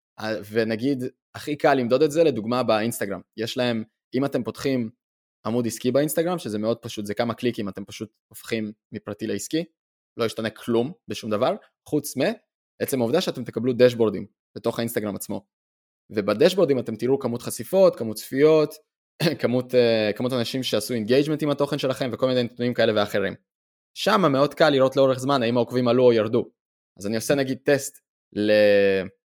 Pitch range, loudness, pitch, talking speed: 110-135 Hz, -23 LUFS, 120 Hz, 160 wpm